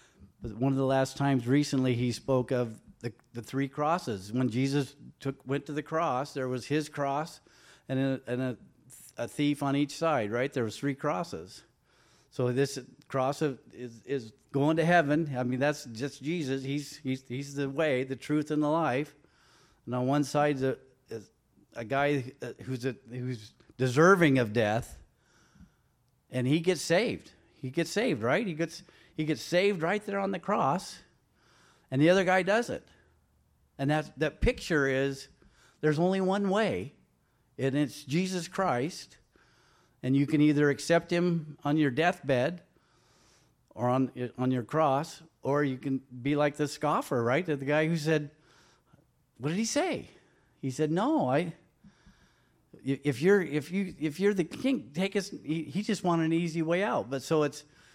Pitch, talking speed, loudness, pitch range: 145 Hz, 175 wpm, -30 LUFS, 130-165 Hz